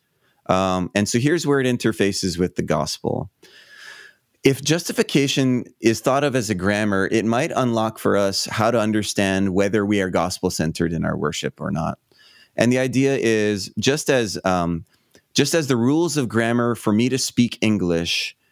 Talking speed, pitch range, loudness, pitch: 175 wpm, 100-130 Hz, -20 LUFS, 115 Hz